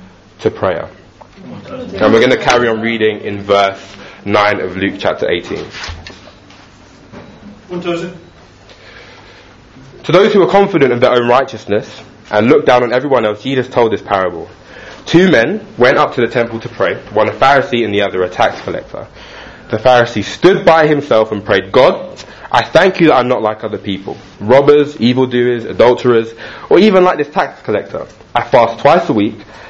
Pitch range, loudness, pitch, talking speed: 105-140 Hz, -12 LUFS, 120 Hz, 170 wpm